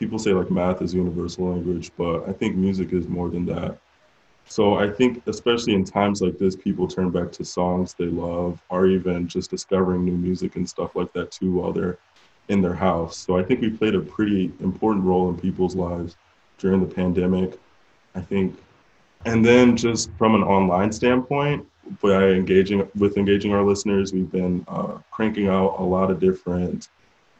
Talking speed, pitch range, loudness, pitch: 185 wpm, 90-100 Hz, -22 LUFS, 95 Hz